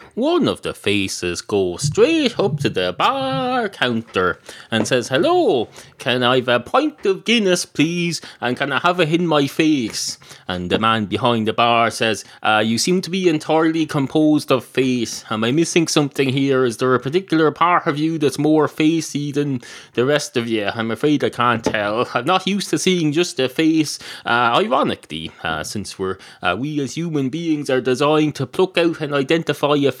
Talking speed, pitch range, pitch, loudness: 195 wpm, 120-165 Hz, 145 Hz, -18 LUFS